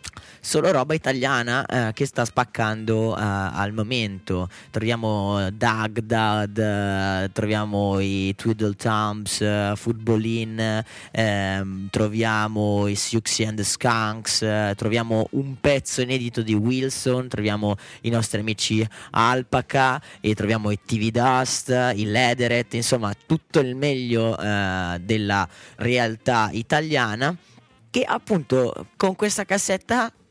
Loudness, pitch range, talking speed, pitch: -23 LUFS, 105-125 Hz, 115 wpm, 110 Hz